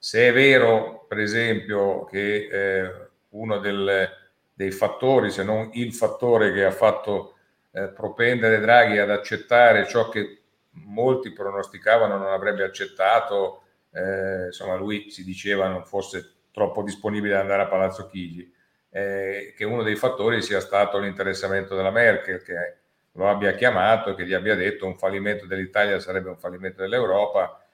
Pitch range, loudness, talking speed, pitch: 95-110 Hz, -22 LUFS, 150 wpm, 100 Hz